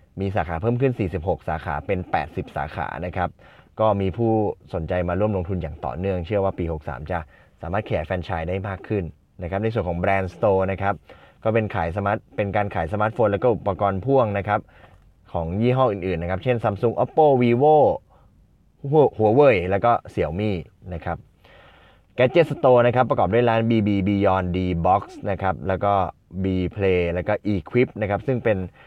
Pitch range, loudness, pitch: 90-110 Hz, -22 LUFS, 100 Hz